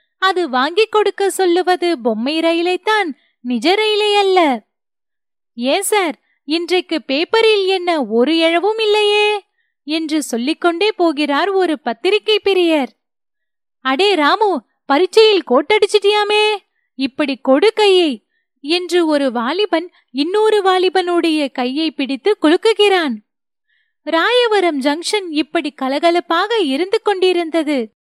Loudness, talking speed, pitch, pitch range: -15 LUFS, 95 wpm, 345 Hz, 290-410 Hz